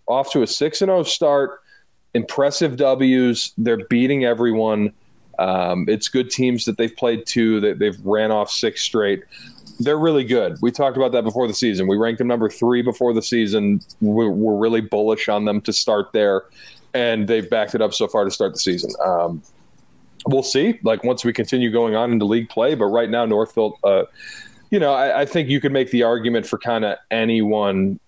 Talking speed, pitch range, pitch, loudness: 200 wpm, 110-130 Hz, 115 Hz, -19 LUFS